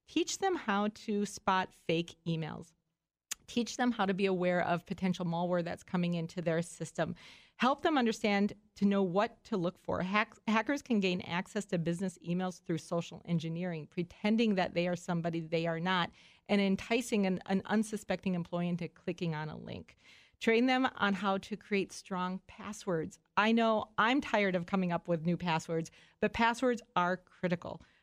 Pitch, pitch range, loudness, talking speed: 185 Hz, 175-210 Hz, -33 LUFS, 175 wpm